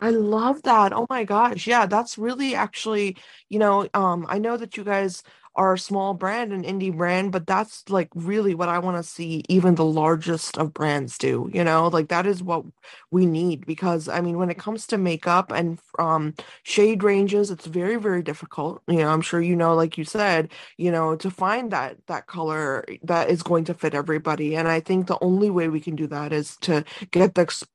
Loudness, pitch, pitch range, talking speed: -23 LUFS, 180 Hz, 165-200 Hz, 220 wpm